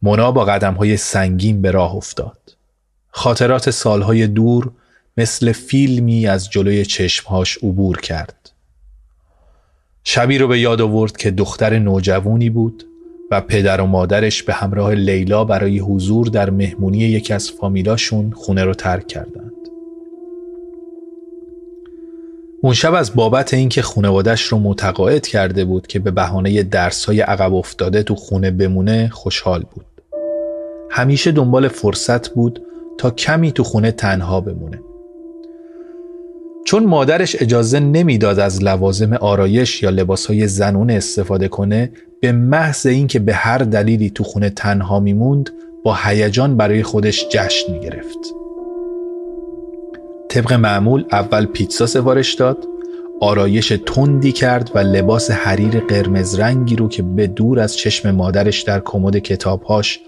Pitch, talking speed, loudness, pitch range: 110 Hz, 130 wpm, -15 LUFS, 100-135 Hz